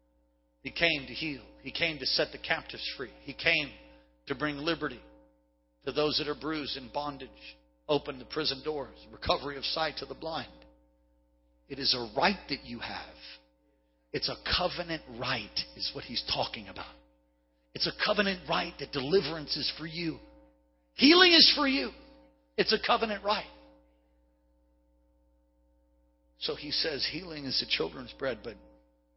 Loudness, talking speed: -29 LUFS, 155 wpm